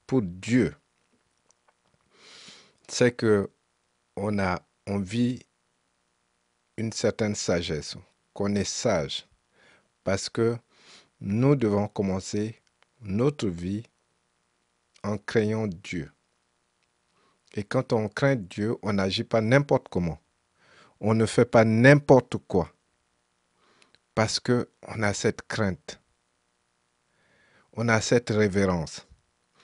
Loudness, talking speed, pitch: -26 LUFS, 100 wpm, 100 Hz